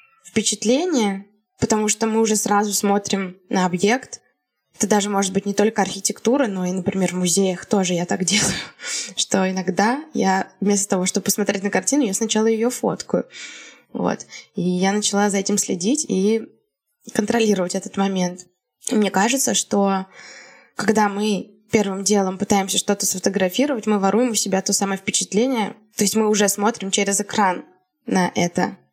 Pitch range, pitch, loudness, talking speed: 195-220 Hz, 205 Hz, -20 LUFS, 160 wpm